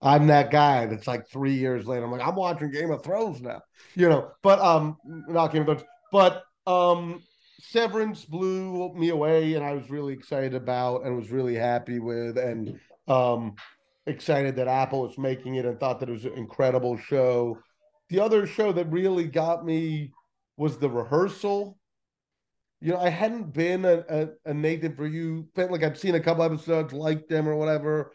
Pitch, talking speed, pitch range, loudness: 155 Hz, 190 wpm, 130-175 Hz, -25 LUFS